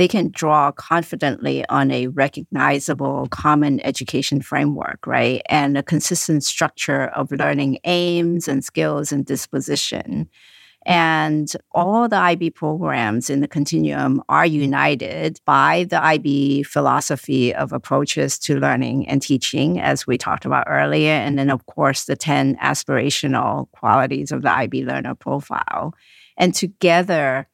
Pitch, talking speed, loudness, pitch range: 145 Hz, 135 wpm, -19 LUFS, 135-160 Hz